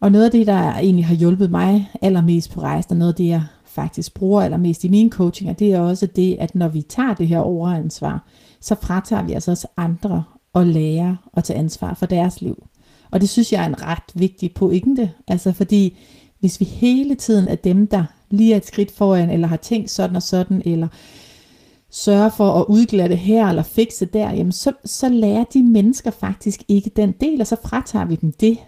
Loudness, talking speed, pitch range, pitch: -18 LUFS, 220 wpm, 175-215 Hz, 195 Hz